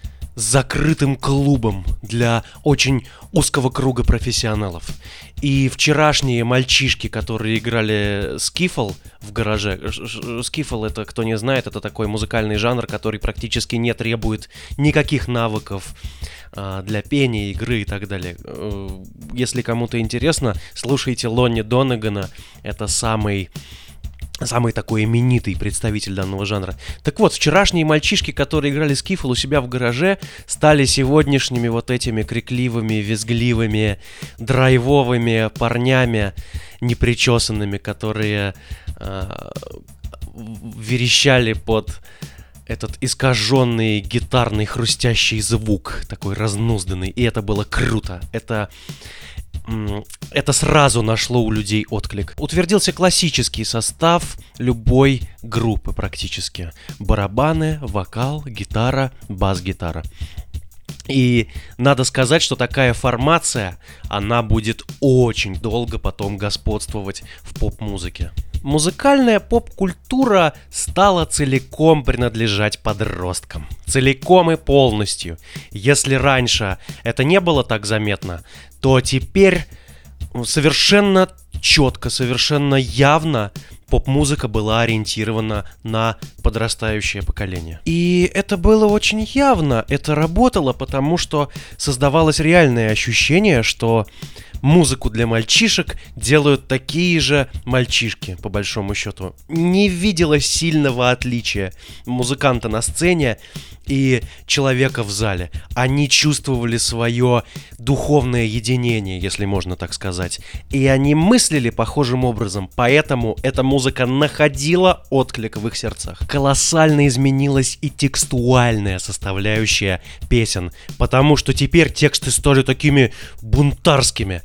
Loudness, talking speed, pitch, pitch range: -17 LUFS, 105 wpm, 115 Hz, 105-140 Hz